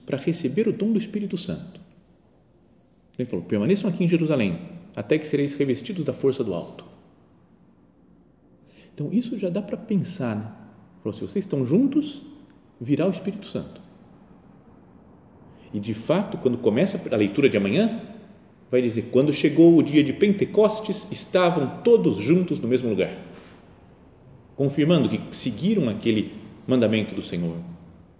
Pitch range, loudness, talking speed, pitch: 125-200 Hz, -23 LUFS, 145 wpm, 165 Hz